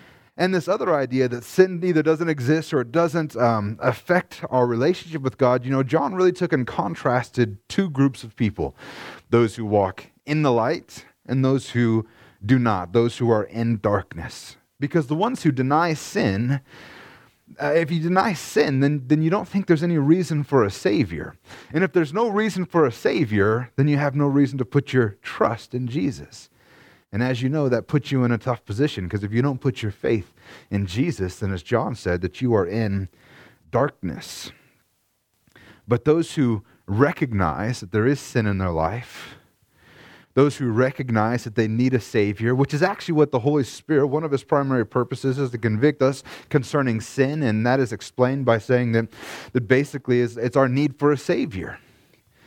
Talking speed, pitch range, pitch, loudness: 190 wpm, 115-150 Hz, 130 Hz, -22 LUFS